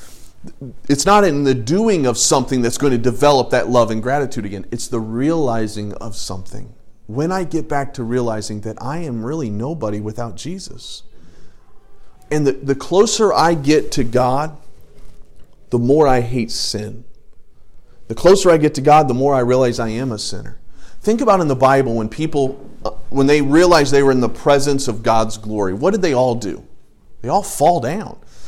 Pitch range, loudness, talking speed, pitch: 115-150 Hz, -16 LUFS, 185 wpm, 130 Hz